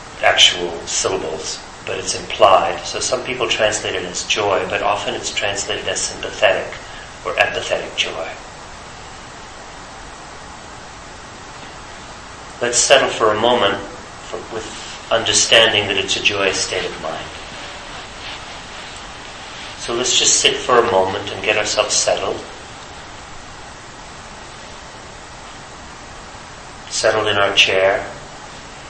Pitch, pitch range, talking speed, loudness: 110 Hz, 100-120 Hz, 105 wpm, -16 LUFS